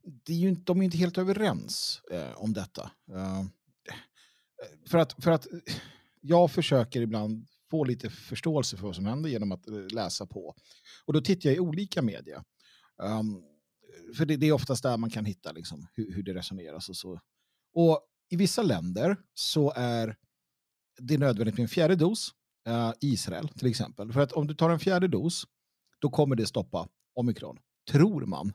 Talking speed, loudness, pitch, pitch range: 180 wpm, -29 LUFS, 135 Hz, 110-170 Hz